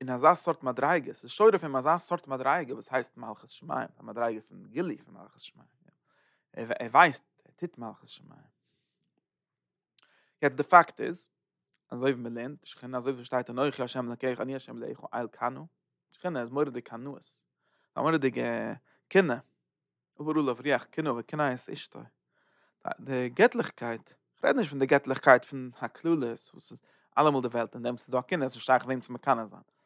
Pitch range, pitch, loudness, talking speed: 120-150 Hz, 130 Hz, -29 LUFS, 185 wpm